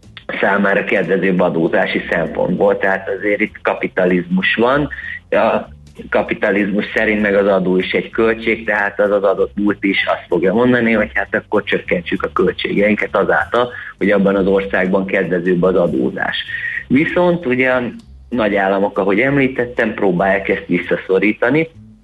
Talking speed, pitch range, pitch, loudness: 140 wpm, 95-115 Hz, 100 Hz, -16 LUFS